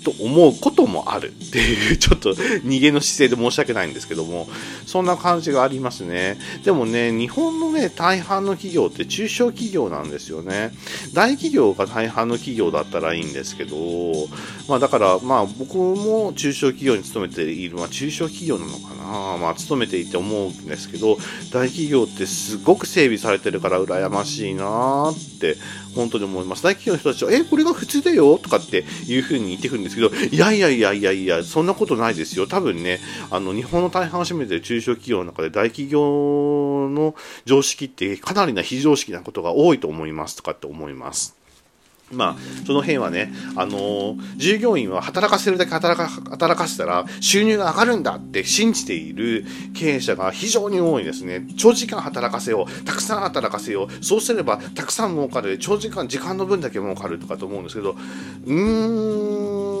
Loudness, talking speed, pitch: -20 LUFS, 375 characters per minute, 135 Hz